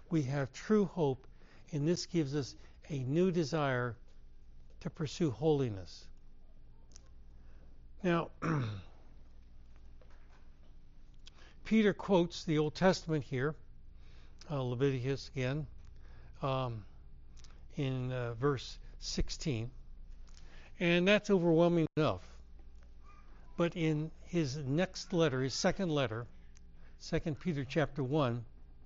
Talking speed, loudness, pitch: 95 wpm, -34 LUFS, 130 Hz